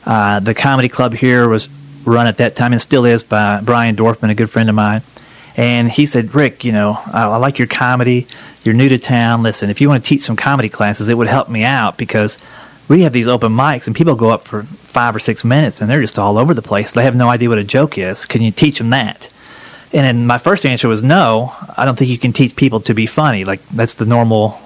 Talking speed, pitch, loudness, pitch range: 260 wpm, 120 Hz, -13 LUFS, 110-135 Hz